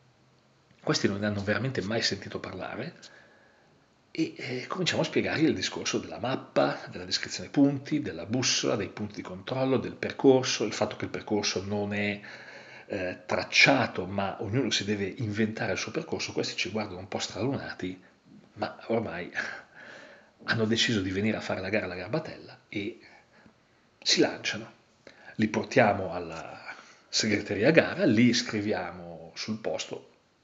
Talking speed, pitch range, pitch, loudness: 150 wpm, 95-120 Hz, 105 Hz, -29 LUFS